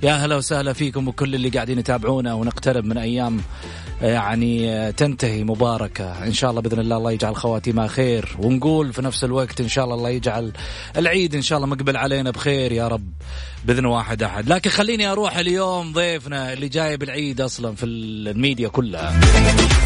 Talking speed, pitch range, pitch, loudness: 170 wpm, 115-140 Hz, 125 Hz, -20 LUFS